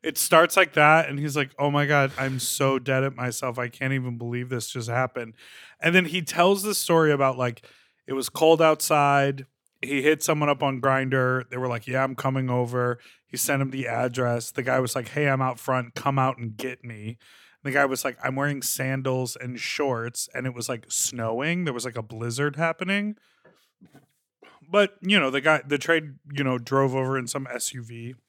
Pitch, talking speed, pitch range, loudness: 135 Hz, 210 wpm, 125-145 Hz, -24 LUFS